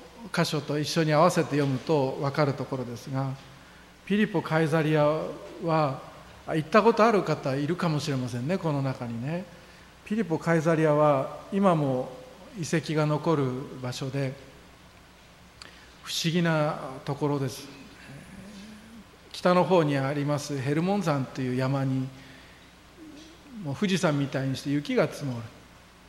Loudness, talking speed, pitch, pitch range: -27 LUFS, 265 characters per minute, 150 Hz, 135-165 Hz